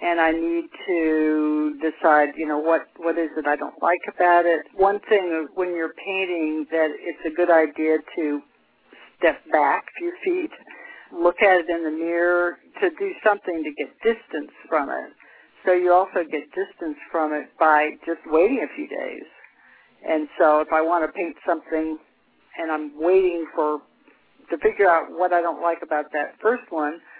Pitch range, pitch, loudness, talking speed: 155-190 Hz, 170 Hz, -22 LUFS, 180 wpm